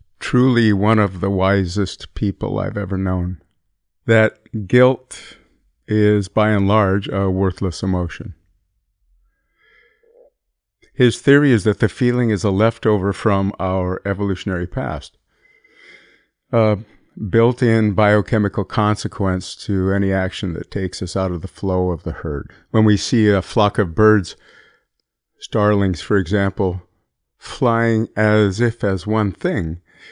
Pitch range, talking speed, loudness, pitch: 95-115 Hz, 130 wpm, -18 LUFS, 105 Hz